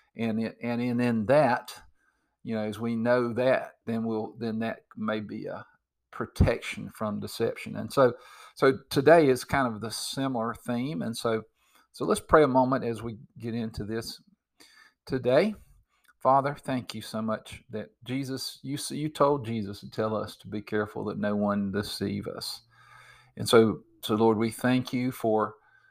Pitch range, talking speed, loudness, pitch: 110-130 Hz, 170 wpm, -28 LUFS, 115 Hz